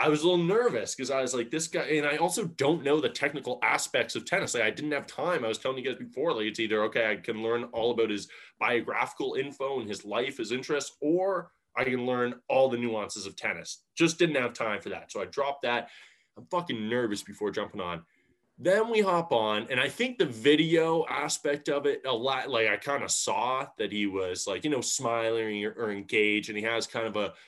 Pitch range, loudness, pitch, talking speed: 110-155 Hz, -29 LUFS, 130 Hz, 240 wpm